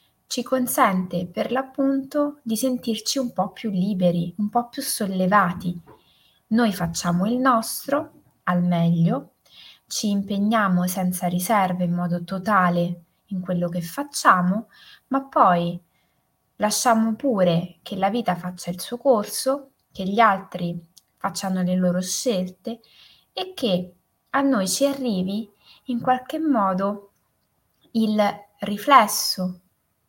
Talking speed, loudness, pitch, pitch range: 120 wpm, -23 LUFS, 205 Hz, 180-250 Hz